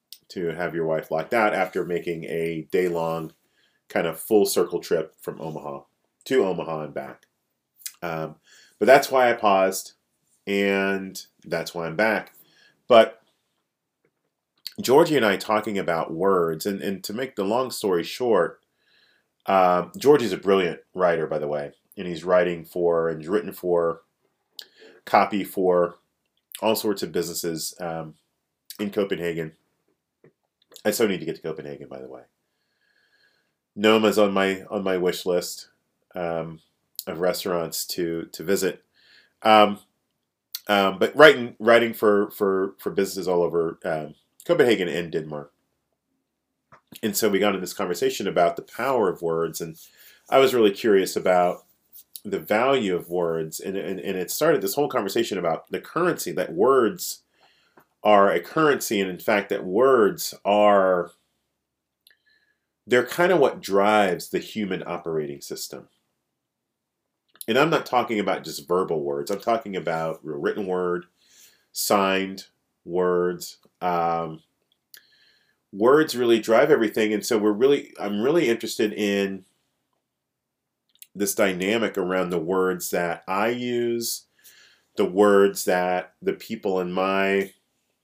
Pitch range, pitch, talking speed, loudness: 85-105 Hz, 95 Hz, 140 wpm, -23 LUFS